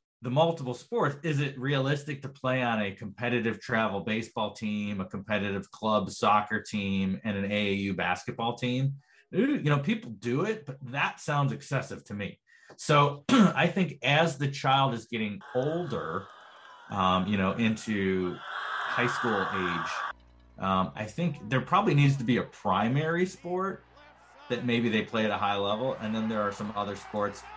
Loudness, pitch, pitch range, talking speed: -29 LUFS, 120 Hz, 105-145 Hz, 170 wpm